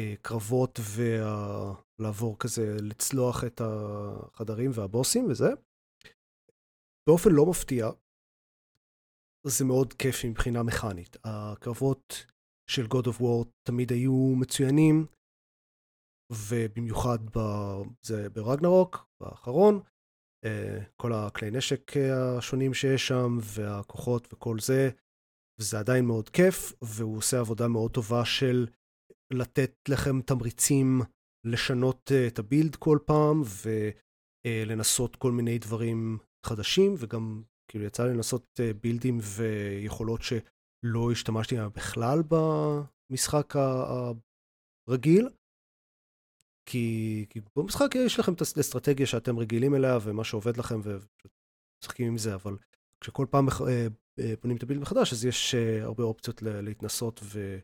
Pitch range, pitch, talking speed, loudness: 110-130 Hz, 120 Hz, 110 wpm, -28 LUFS